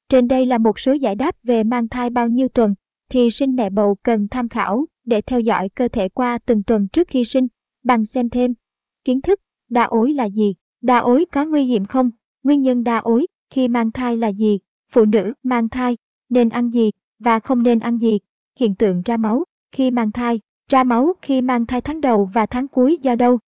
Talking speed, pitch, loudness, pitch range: 220 wpm, 240 Hz, -18 LUFS, 225-255 Hz